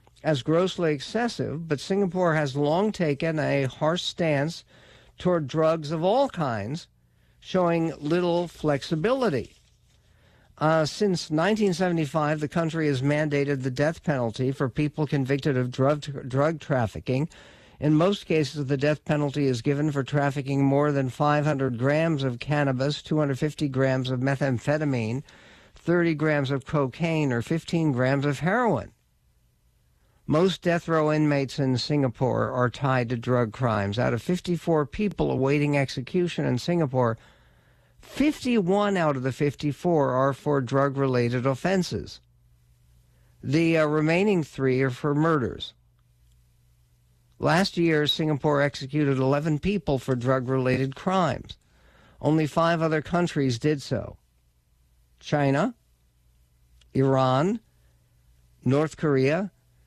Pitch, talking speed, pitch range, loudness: 145 Hz, 120 wpm, 130-160 Hz, -25 LUFS